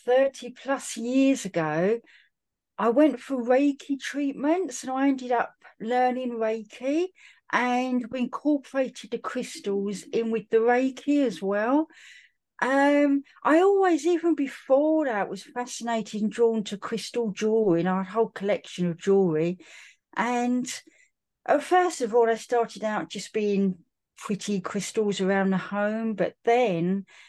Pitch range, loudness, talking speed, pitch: 210-275 Hz, -26 LUFS, 135 wpm, 240 Hz